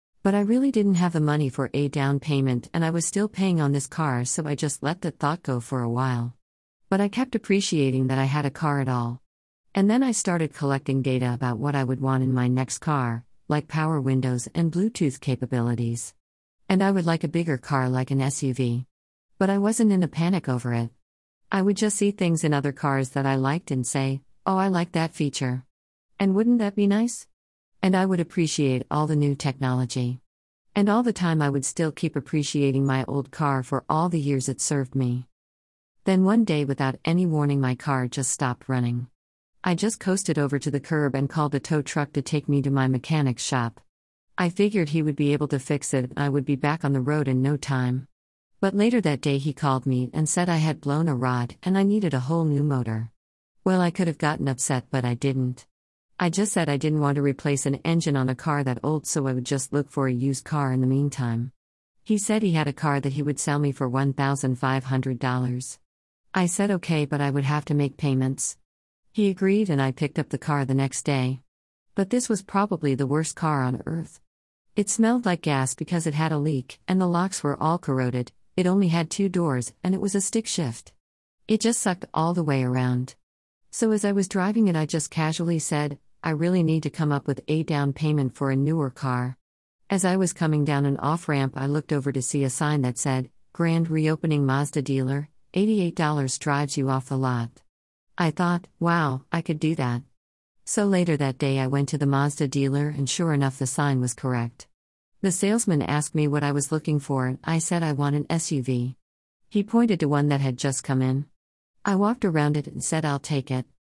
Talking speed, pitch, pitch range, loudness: 220 wpm, 145 Hz, 130-165 Hz, -25 LUFS